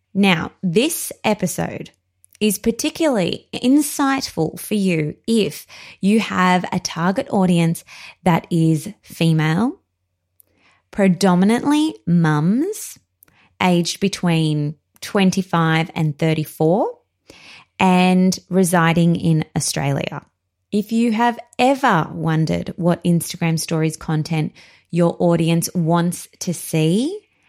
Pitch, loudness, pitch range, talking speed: 175 Hz, -19 LUFS, 160-205 Hz, 90 wpm